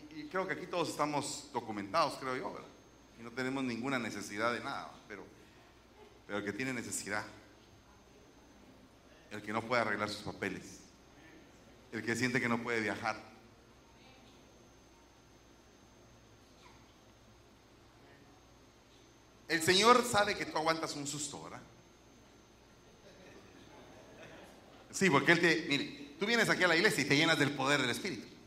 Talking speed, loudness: 135 wpm, -33 LUFS